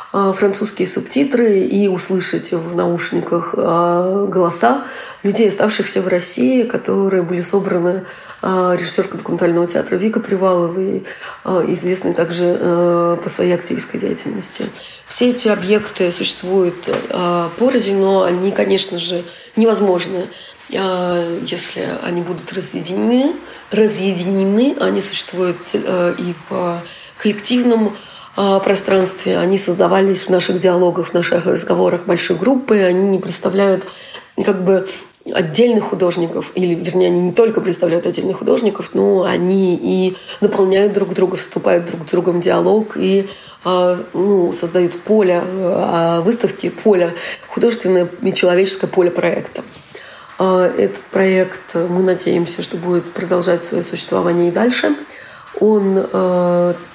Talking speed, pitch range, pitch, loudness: 115 wpm, 175-200 Hz, 185 Hz, -15 LUFS